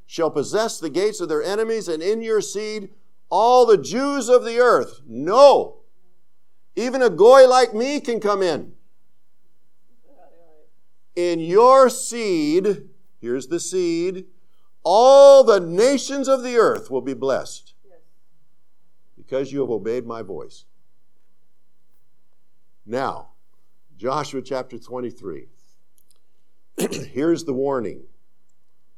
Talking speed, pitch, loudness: 110 wpm, 200 Hz, -18 LUFS